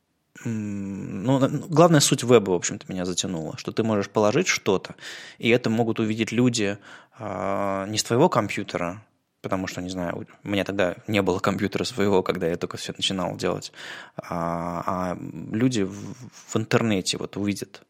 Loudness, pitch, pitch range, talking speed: -24 LUFS, 100 Hz, 90-115 Hz, 160 wpm